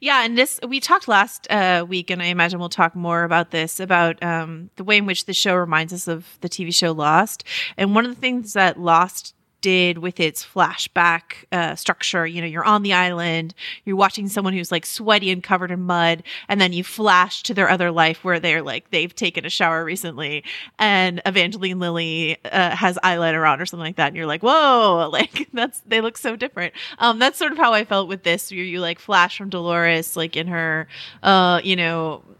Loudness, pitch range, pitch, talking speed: -19 LUFS, 170-200 Hz, 180 Hz, 220 wpm